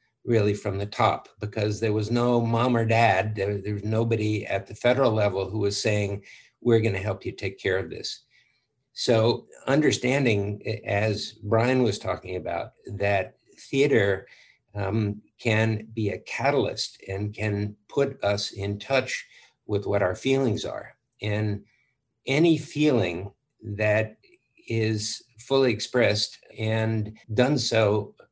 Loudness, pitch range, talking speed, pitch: -25 LUFS, 105-120 Hz, 140 wpm, 110 Hz